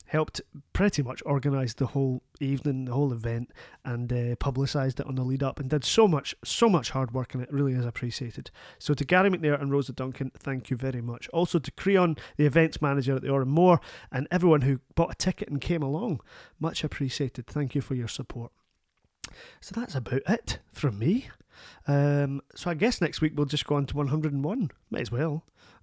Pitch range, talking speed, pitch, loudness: 130-155 Hz, 205 wpm, 140 Hz, -28 LUFS